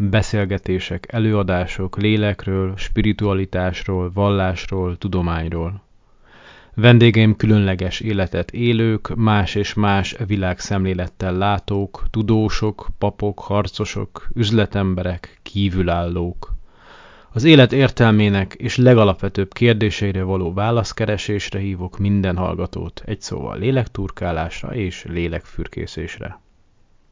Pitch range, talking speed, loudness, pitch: 90-110 Hz, 80 wpm, -19 LUFS, 100 Hz